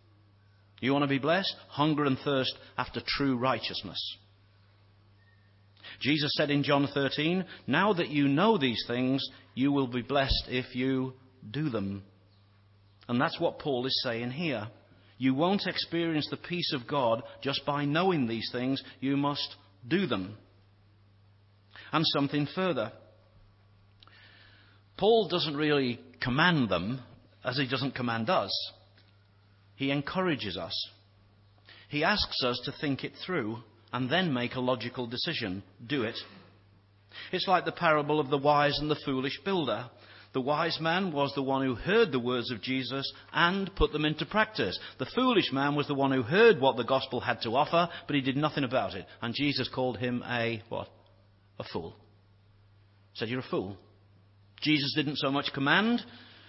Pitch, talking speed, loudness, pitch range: 130 Hz, 160 wpm, -29 LUFS, 100-145 Hz